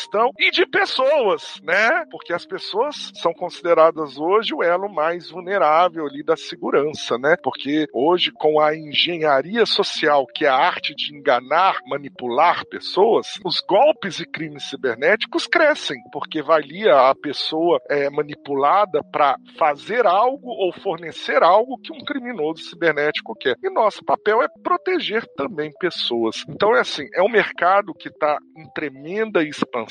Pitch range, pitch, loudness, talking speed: 150-225 Hz, 170 Hz, -19 LUFS, 145 wpm